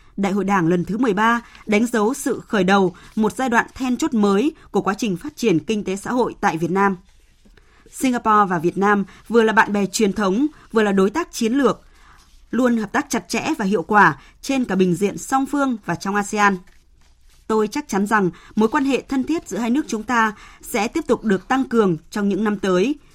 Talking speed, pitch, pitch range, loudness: 225 wpm, 215 Hz, 195-245 Hz, -20 LUFS